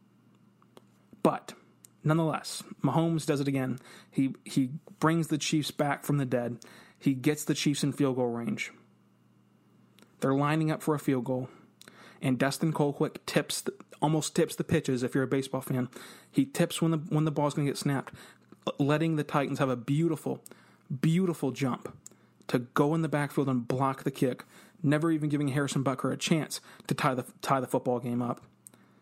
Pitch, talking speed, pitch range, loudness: 145 Hz, 180 wpm, 135-155 Hz, -30 LUFS